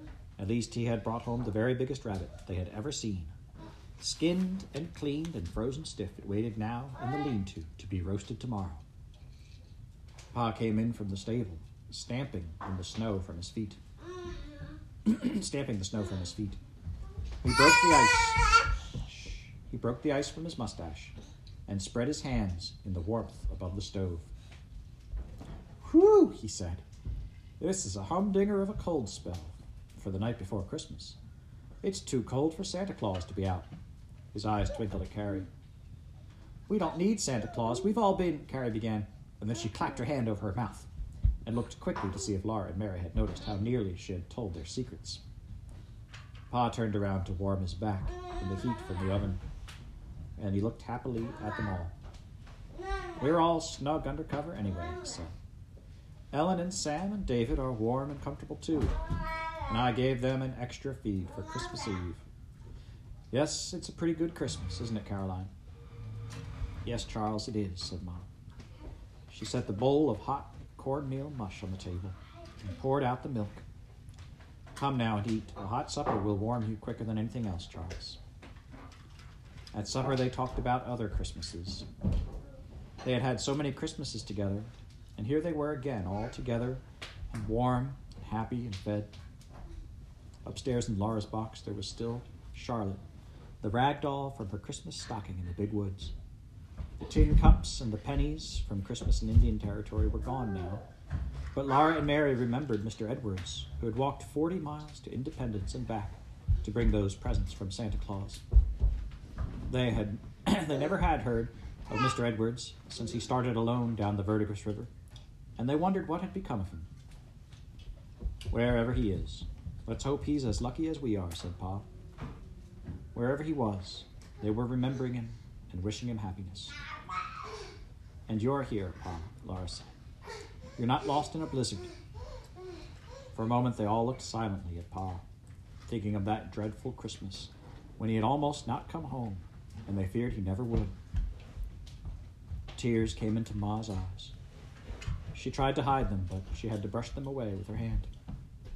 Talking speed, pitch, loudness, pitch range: 170 wpm, 110 Hz, -34 LUFS, 95-125 Hz